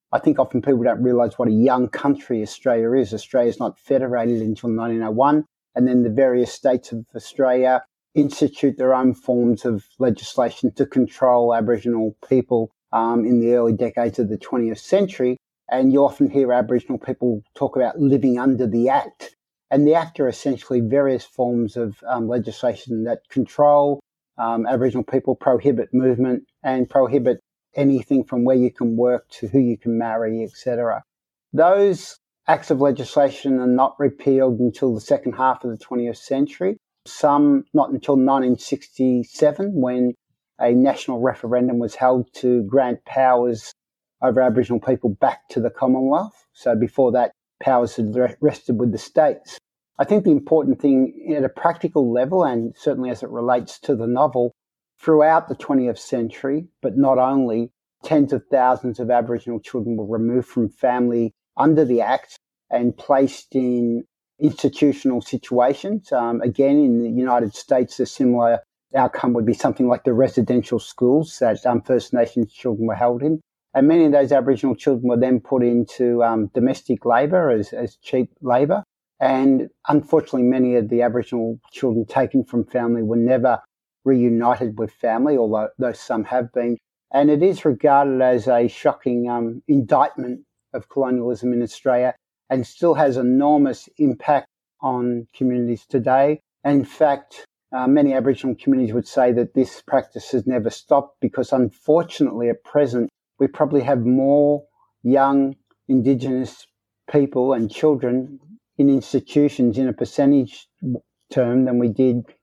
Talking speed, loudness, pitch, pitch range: 155 wpm, -19 LUFS, 125 Hz, 120-140 Hz